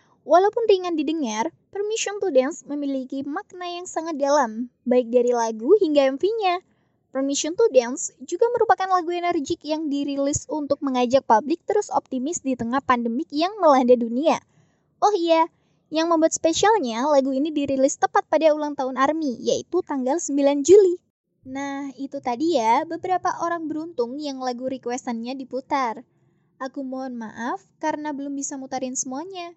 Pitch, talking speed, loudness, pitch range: 290 Hz, 145 wpm, -22 LUFS, 265-345 Hz